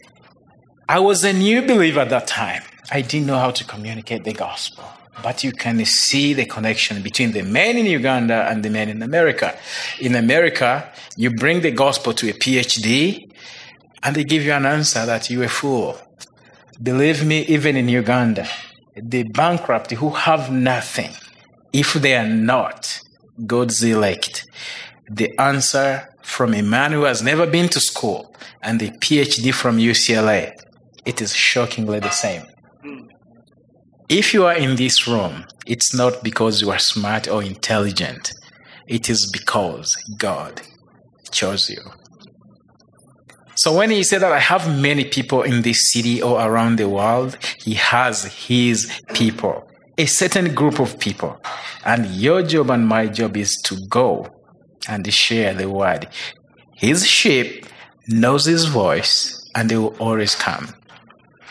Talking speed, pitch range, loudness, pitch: 150 wpm, 110-140 Hz, -17 LUFS, 120 Hz